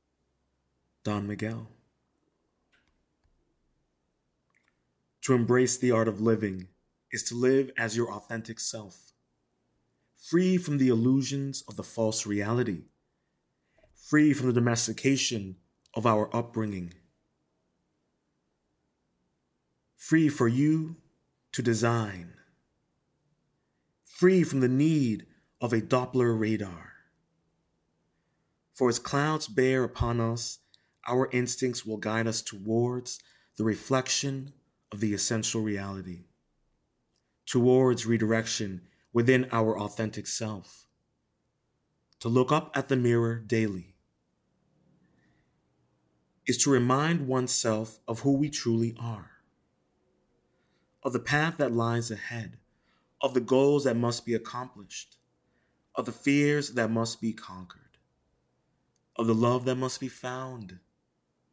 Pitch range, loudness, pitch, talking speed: 105-130 Hz, -28 LUFS, 115 Hz, 105 wpm